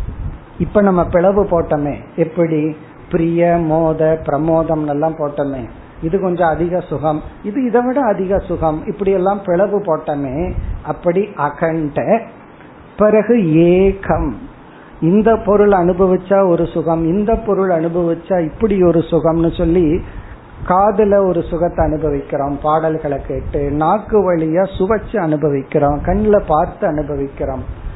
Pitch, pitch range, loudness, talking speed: 165 Hz, 155-195 Hz, -15 LUFS, 105 wpm